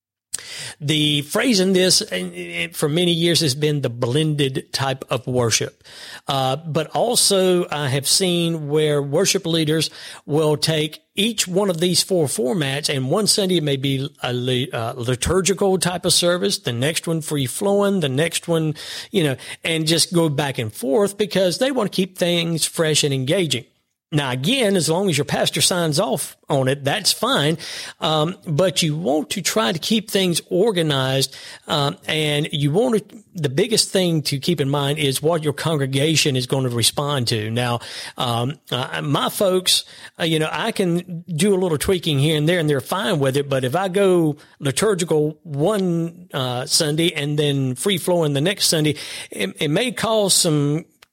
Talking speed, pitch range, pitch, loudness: 180 wpm, 145-185 Hz, 160 Hz, -19 LUFS